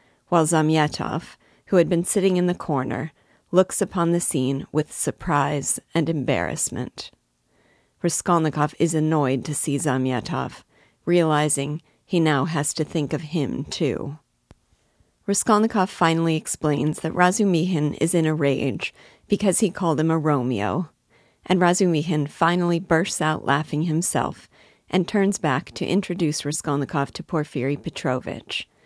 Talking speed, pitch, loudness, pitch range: 130 wpm, 155 Hz, -22 LUFS, 145-175 Hz